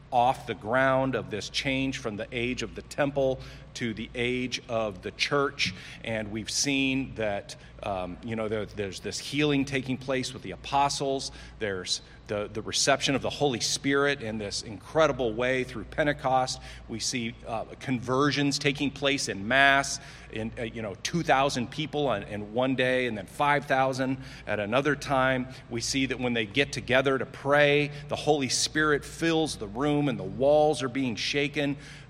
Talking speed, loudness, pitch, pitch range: 180 wpm, -28 LUFS, 130 Hz, 115-140 Hz